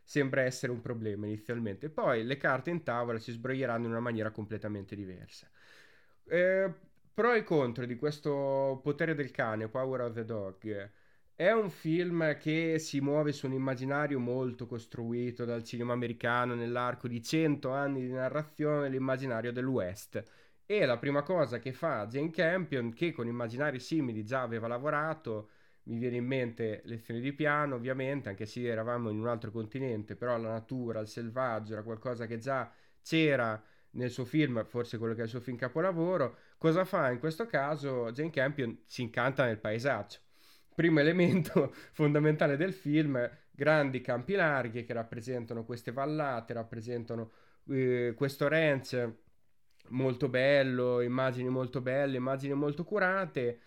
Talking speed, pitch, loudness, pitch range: 155 wpm, 130 Hz, -33 LUFS, 120-145 Hz